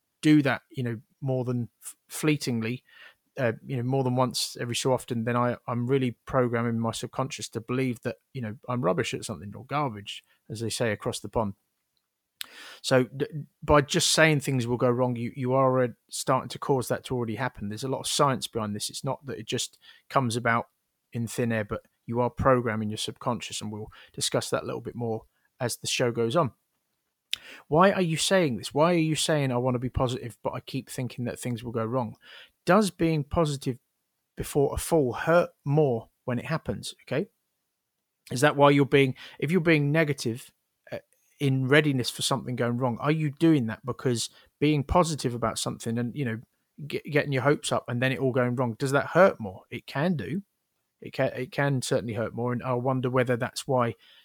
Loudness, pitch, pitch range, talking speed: -27 LUFS, 125 Hz, 120-145 Hz, 210 wpm